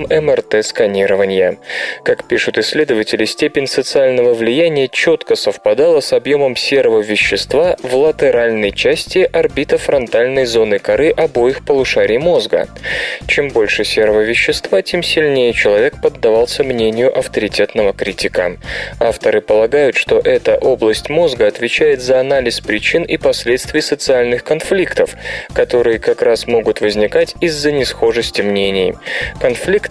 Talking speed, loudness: 115 wpm, -13 LUFS